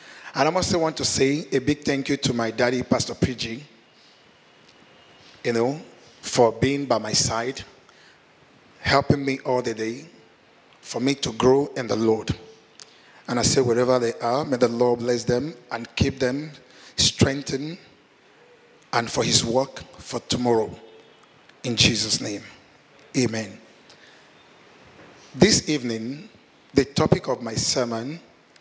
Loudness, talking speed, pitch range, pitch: -23 LUFS, 140 wpm, 115-140 Hz, 125 Hz